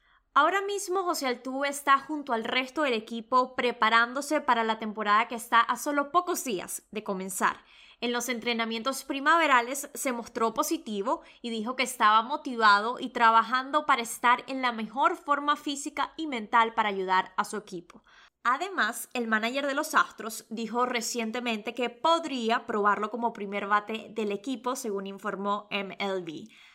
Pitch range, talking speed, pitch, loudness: 220-280 Hz, 155 wpm, 240 Hz, -27 LUFS